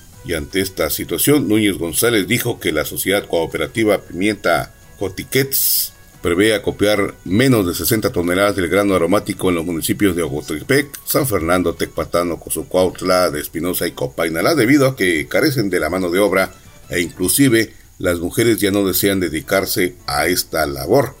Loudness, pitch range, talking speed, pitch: -17 LUFS, 90-105 Hz, 155 wpm, 100 Hz